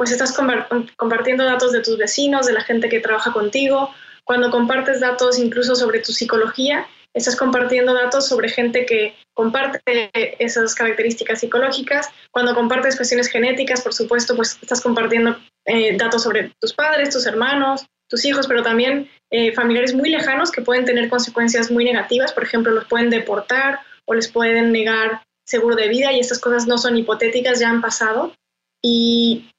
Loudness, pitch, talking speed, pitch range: -17 LUFS, 240 Hz, 165 wpm, 230-255 Hz